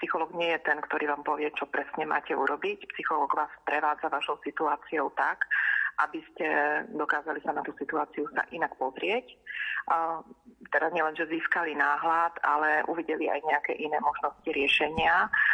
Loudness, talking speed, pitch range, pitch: -28 LUFS, 150 wpm, 150-225 Hz, 165 Hz